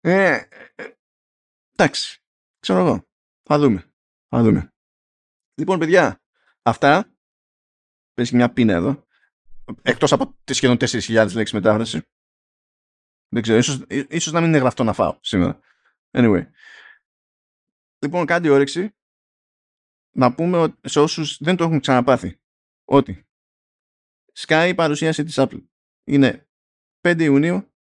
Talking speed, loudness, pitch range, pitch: 120 wpm, -19 LUFS, 115-160 Hz, 140 Hz